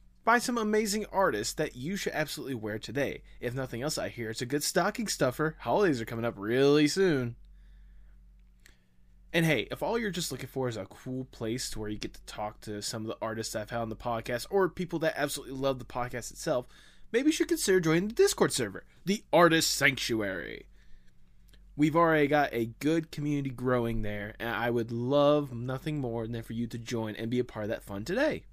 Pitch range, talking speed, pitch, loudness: 110-155 Hz, 210 wpm, 125 Hz, -30 LUFS